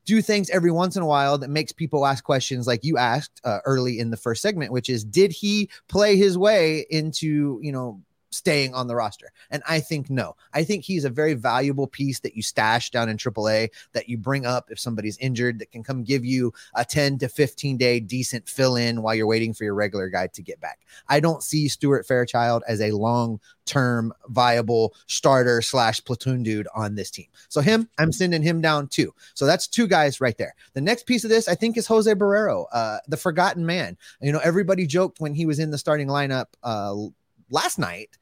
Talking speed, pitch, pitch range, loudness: 220 wpm, 135 Hz, 120-160 Hz, -23 LUFS